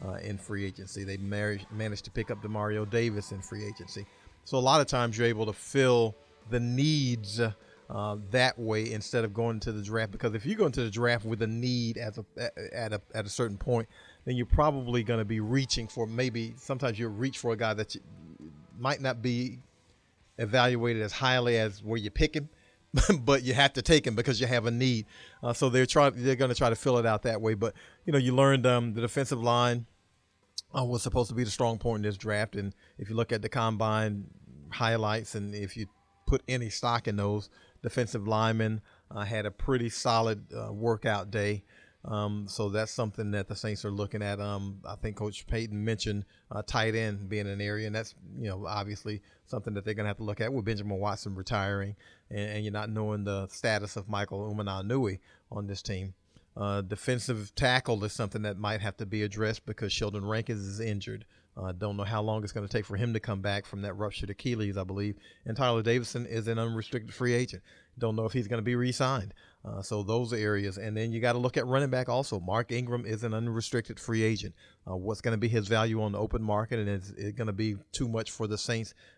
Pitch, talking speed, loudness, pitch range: 110 Hz, 225 wpm, -31 LUFS, 105-120 Hz